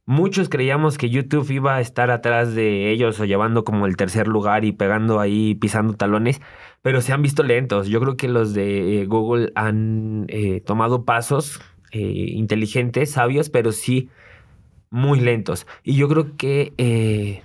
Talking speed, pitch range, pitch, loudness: 165 wpm, 105-130 Hz, 115 Hz, -20 LUFS